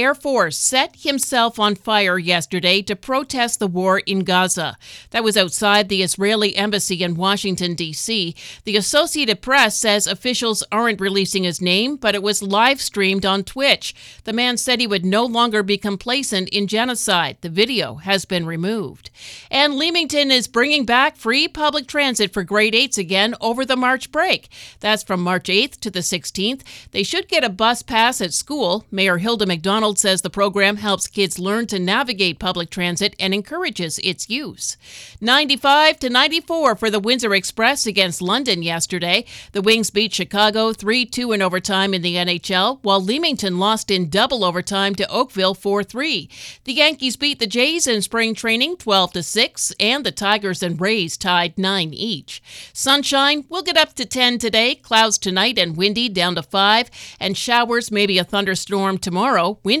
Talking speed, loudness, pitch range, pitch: 170 wpm, -18 LUFS, 190-245 Hz, 210 Hz